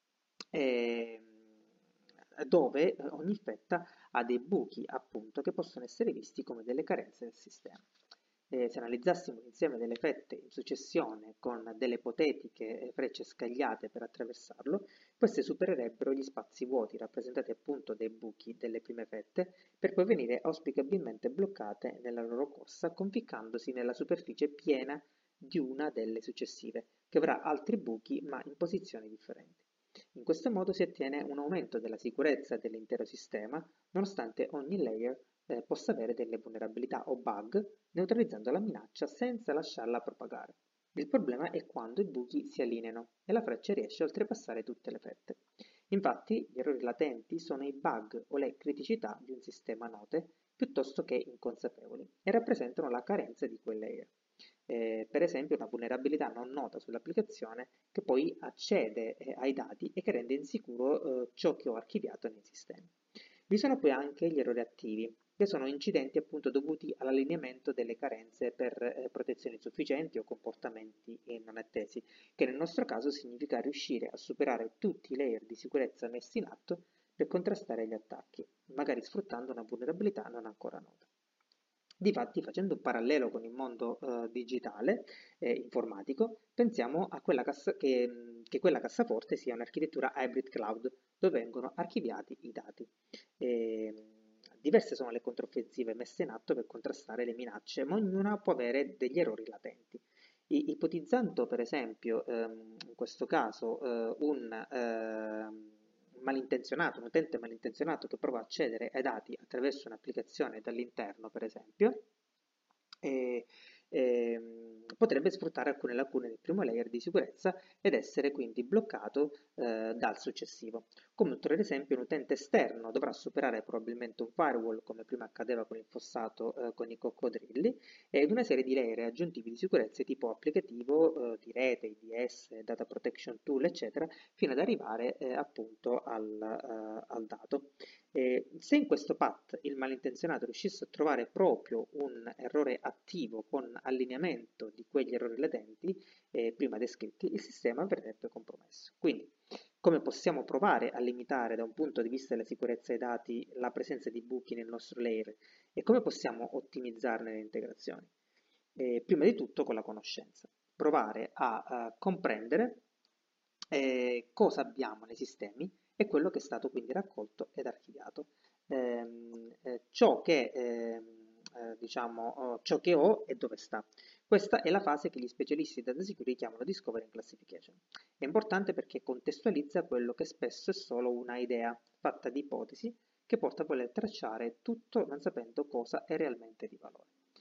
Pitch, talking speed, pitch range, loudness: 125 Hz, 155 wpm, 115-160 Hz, -36 LUFS